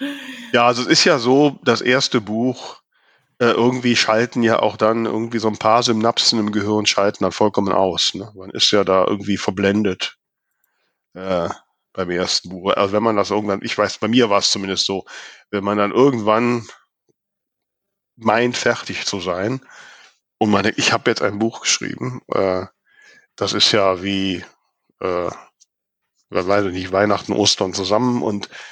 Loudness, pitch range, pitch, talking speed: -18 LUFS, 100-120 Hz, 105 Hz, 170 wpm